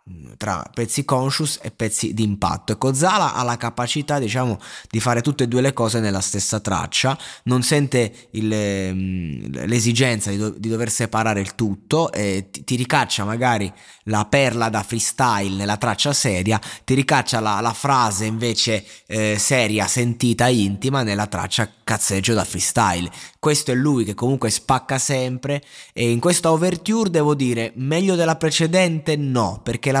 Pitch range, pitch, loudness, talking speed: 105-135 Hz, 120 Hz, -20 LUFS, 155 wpm